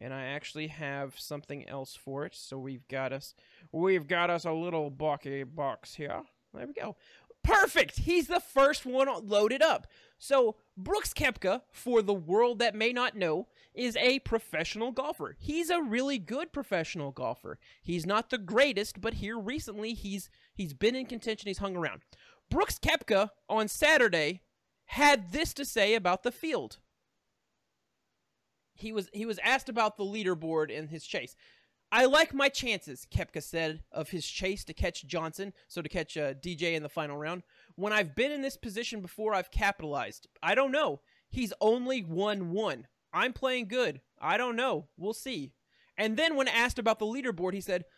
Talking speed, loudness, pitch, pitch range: 175 wpm, -31 LUFS, 210 Hz, 165-255 Hz